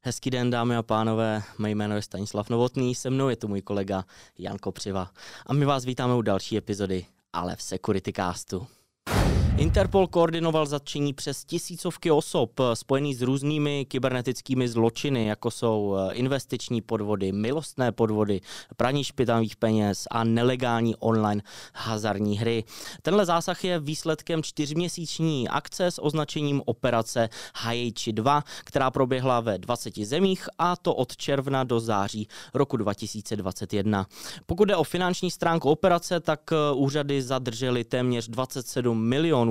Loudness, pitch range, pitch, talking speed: -26 LUFS, 110-145 Hz, 125 Hz, 135 wpm